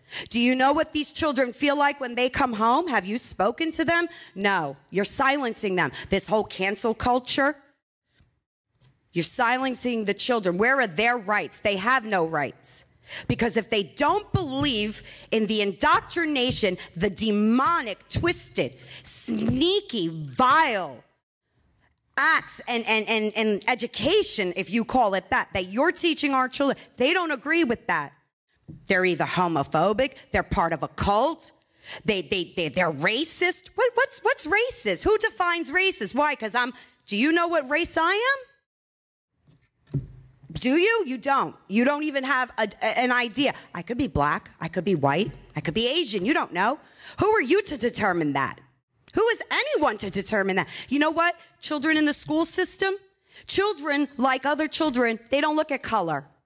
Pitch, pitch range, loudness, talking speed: 245 Hz, 195-305 Hz, -24 LUFS, 165 wpm